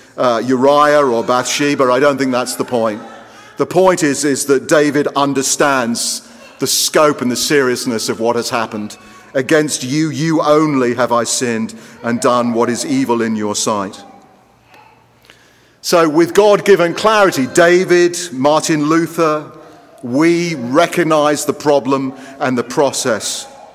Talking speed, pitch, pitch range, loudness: 140 wpm, 140 Hz, 125-160 Hz, -14 LUFS